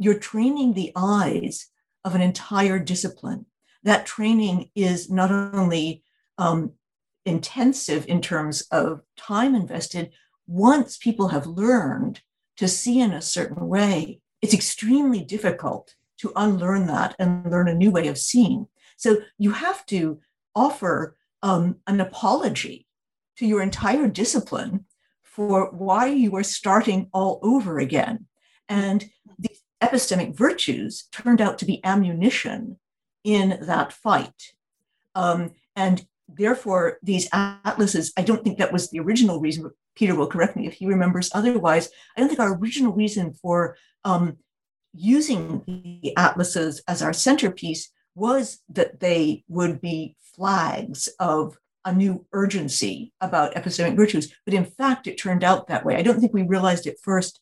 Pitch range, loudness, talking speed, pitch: 175-225 Hz, -22 LUFS, 145 wpm, 195 Hz